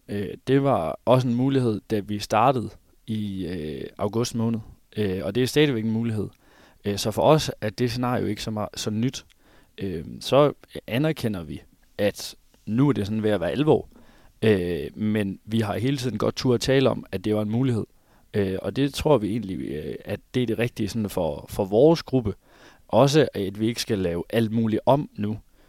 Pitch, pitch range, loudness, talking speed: 110 Hz, 100-125 Hz, -24 LUFS, 205 wpm